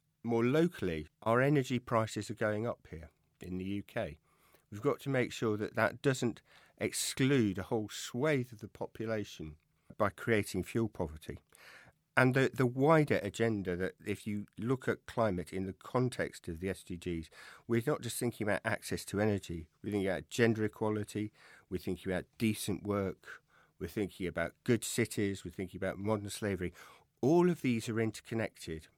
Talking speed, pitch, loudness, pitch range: 170 wpm, 105 Hz, -34 LUFS, 95-120 Hz